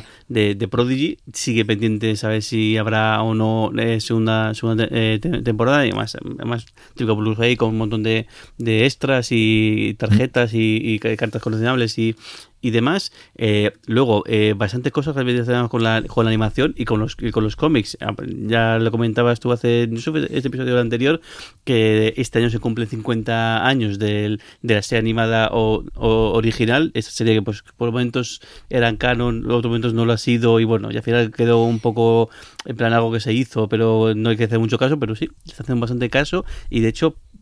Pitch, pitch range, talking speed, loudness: 115 Hz, 110-120 Hz, 200 wpm, -19 LUFS